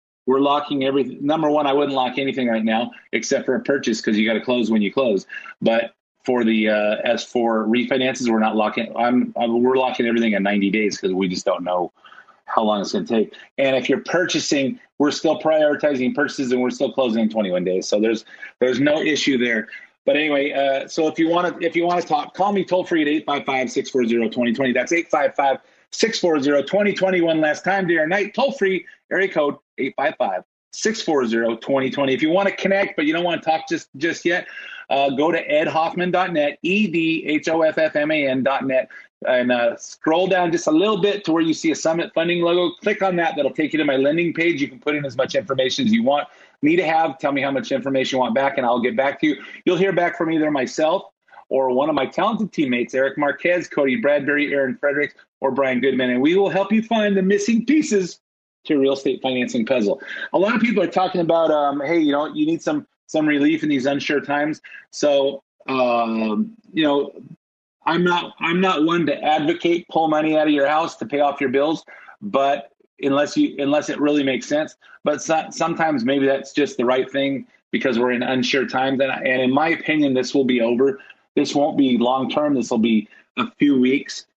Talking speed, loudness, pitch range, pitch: 220 wpm, -20 LUFS, 130-175 Hz, 145 Hz